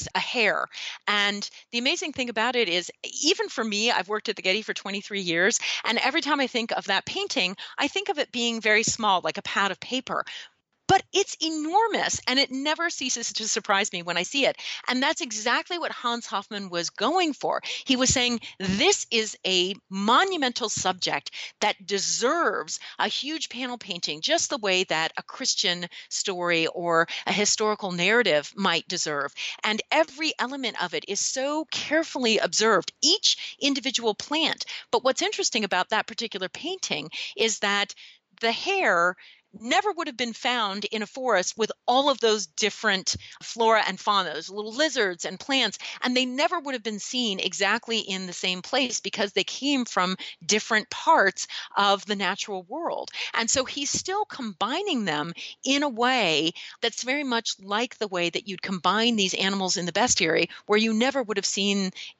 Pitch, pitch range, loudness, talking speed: 225 Hz, 195-265 Hz, -25 LUFS, 180 wpm